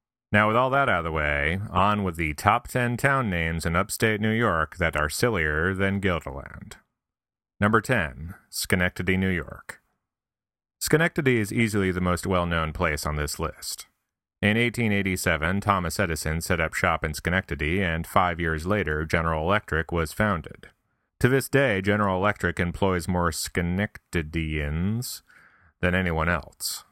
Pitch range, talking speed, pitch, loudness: 80-105 Hz, 155 wpm, 90 Hz, -25 LUFS